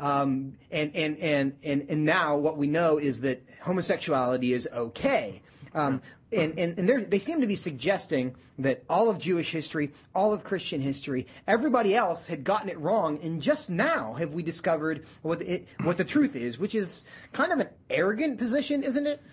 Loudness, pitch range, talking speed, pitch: -28 LUFS, 140-195 Hz, 185 wpm, 160 Hz